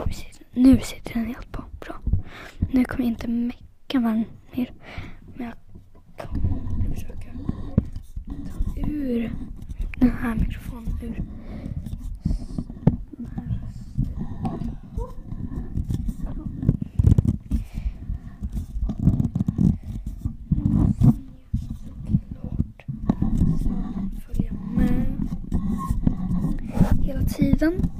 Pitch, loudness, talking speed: 200 Hz, -26 LUFS, 60 wpm